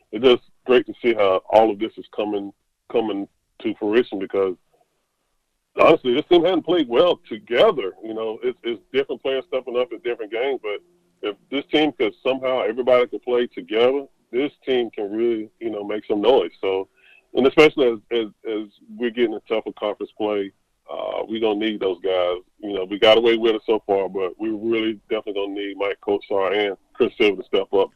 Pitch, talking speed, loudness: 145 Hz, 205 wpm, -21 LUFS